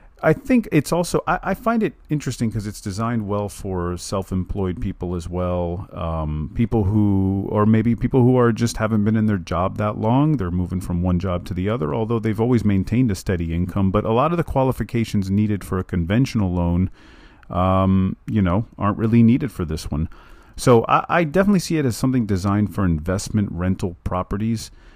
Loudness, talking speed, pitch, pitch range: -21 LUFS, 200 wpm, 105 Hz, 95-120 Hz